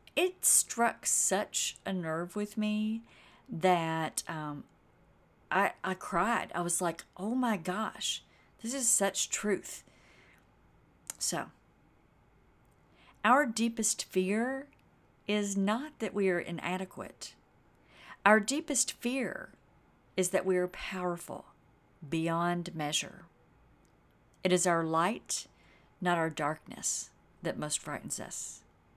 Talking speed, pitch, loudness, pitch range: 110 wpm, 190 Hz, -32 LUFS, 170-220 Hz